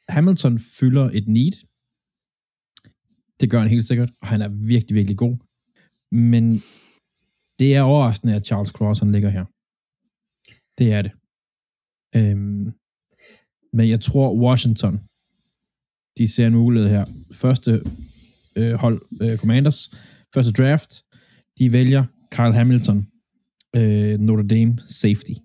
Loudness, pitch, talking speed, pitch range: -19 LUFS, 115 Hz, 125 wpm, 105-130 Hz